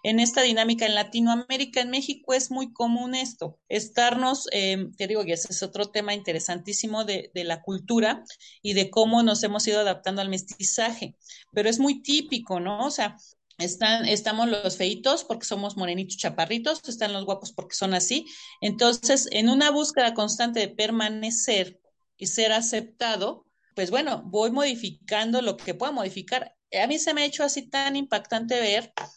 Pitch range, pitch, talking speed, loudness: 200-250 Hz, 220 Hz, 170 wpm, -25 LUFS